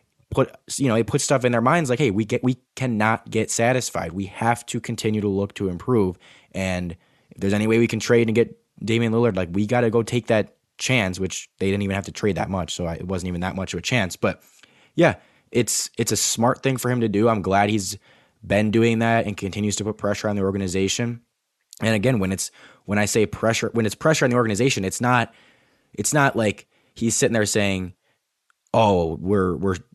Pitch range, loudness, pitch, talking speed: 95-120 Hz, -22 LUFS, 110 Hz, 230 wpm